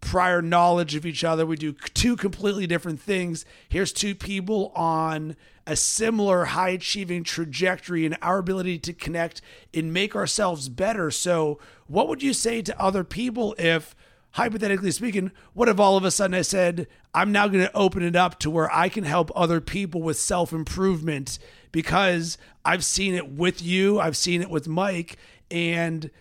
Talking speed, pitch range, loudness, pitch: 170 wpm, 165-195 Hz, -24 LUFS, 180 Hz